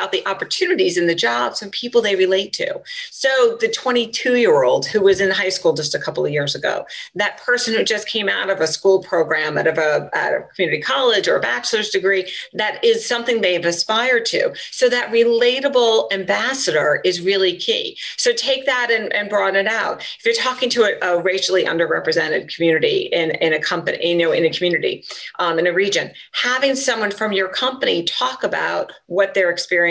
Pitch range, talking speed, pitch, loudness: 185-265 Hz, 200 wpm, 215 Hz, -18 LUFS